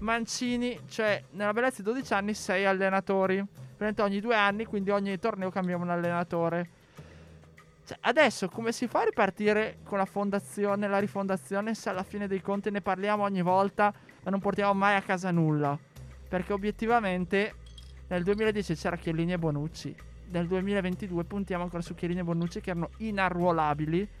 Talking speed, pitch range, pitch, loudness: 160 wpm, 175-205 Hz, 195 Hz, -29 LUFS